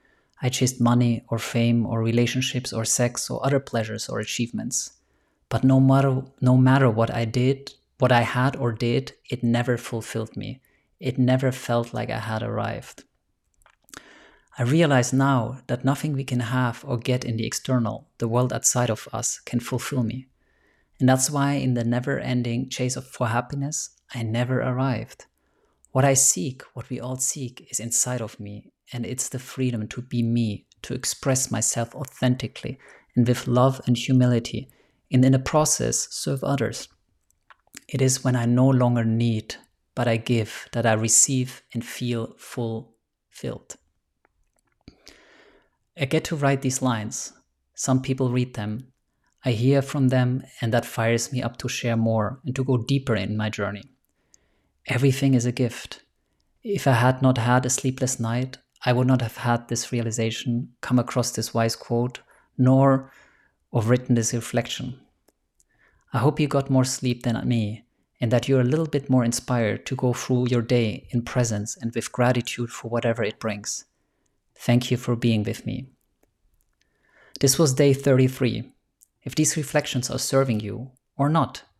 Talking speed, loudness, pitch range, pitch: 165 wpm, -23 LUFS, 115-130 Hz, 125 Hz